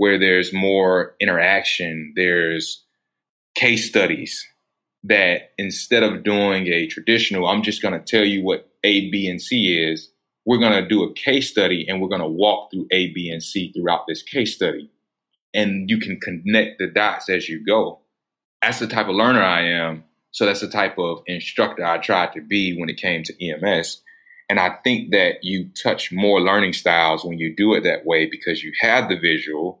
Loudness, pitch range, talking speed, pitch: -19 LUFS, 85-100 Hz, 190 wpm, 90 Hz